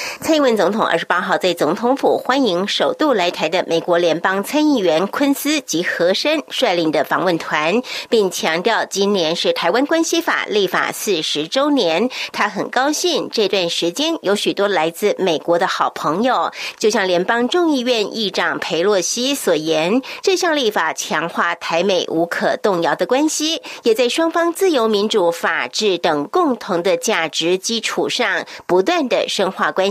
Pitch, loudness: 225 Hz, -17 LUFS